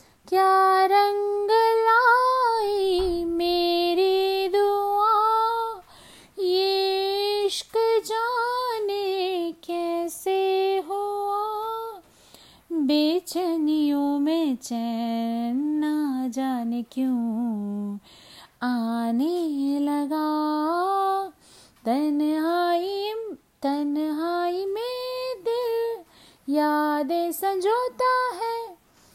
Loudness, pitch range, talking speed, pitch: -24 LUFS, 300-410 Hz, 50 wpm, 365 Hz